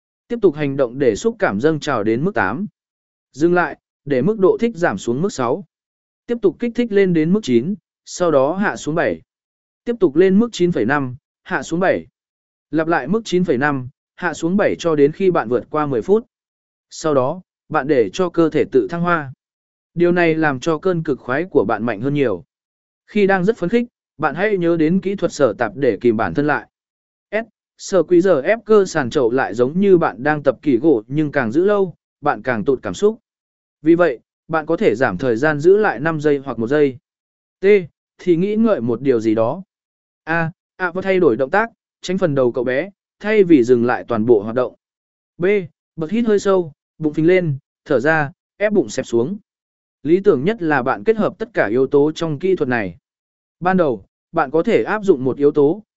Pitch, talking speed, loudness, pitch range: 175 Hz, 220 wpm, -18 LUFS, 150-205 Hz